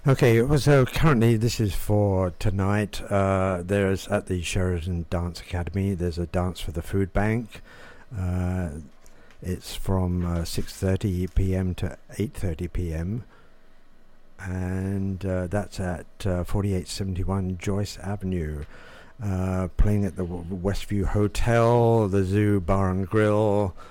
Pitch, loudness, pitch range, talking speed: 95 Hz, -25 LUFS, 90-105 Hz, 120 wpm